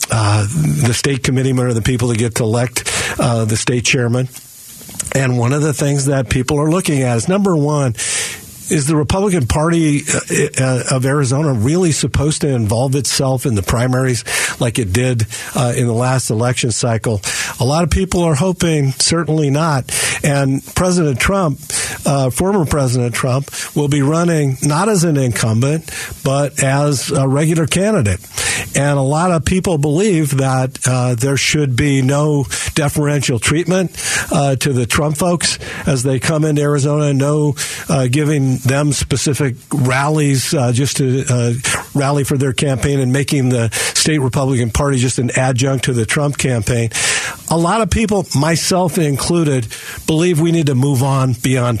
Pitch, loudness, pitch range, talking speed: 140 Hz, -15 LUFS, 125-150 Hz, 165 wpm